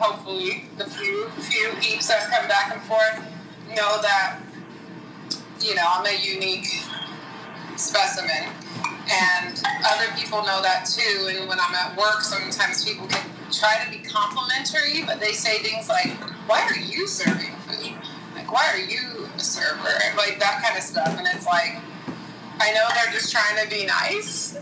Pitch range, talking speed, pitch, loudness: 190-220 Hz, 170 wpm, 210 Hz, -22 LUFS